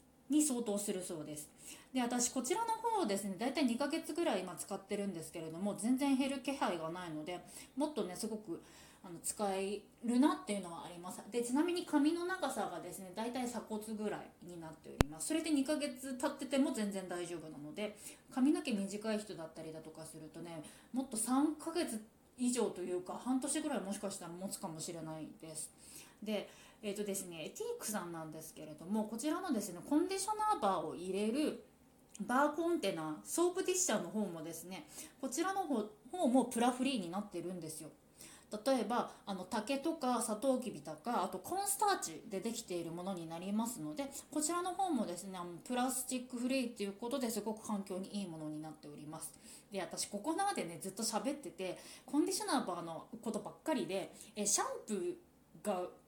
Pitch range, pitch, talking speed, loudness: 180-275 Hz, 220 Hz, 405 characters per minute, -39 LUFS